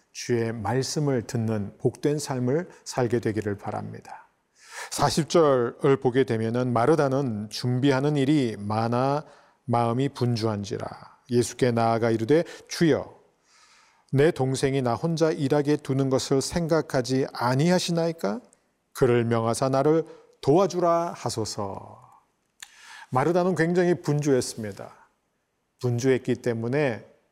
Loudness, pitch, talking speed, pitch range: -25 LUFS, 130 Hz, 255 characters per minute, 115-150 Hz